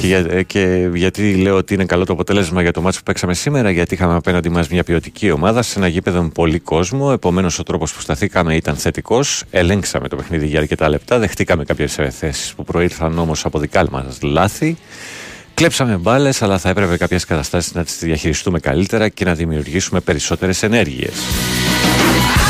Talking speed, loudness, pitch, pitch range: 180 wpm, -16 LUFS, 90 Hz, 80-95 Hz